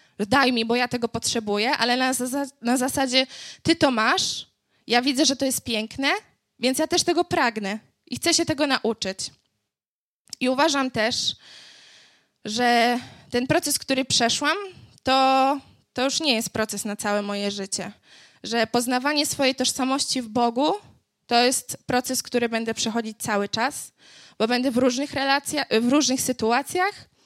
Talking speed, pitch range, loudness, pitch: 155 wpm, 230-280 Hz, -23 LUFS, 255 Hz